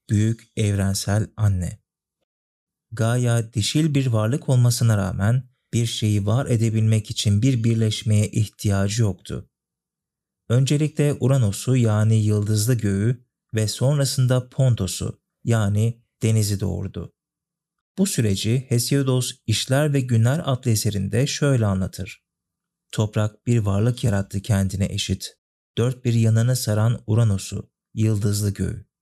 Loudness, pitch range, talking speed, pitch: -22 LUFS, 105-125 Hz, 110 wpm, 115 Hz